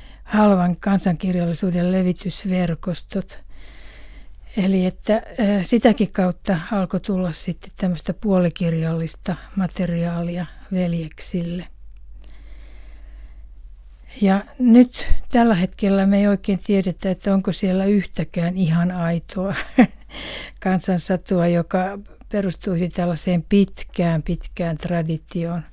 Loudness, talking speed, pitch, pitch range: -21 LUFS, 80 wpm, 180 Hz, 170-195 Hz